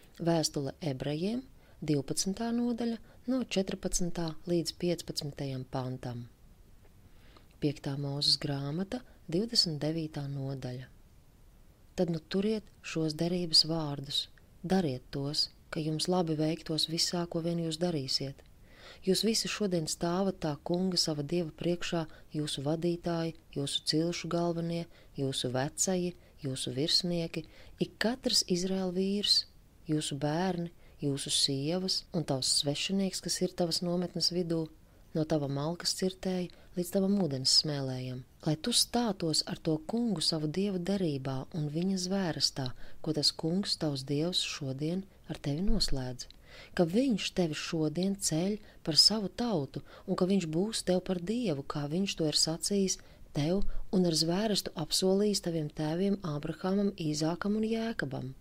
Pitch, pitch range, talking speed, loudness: 165 Hz, 150-185 Hz, 125 wpm, -31 LUFS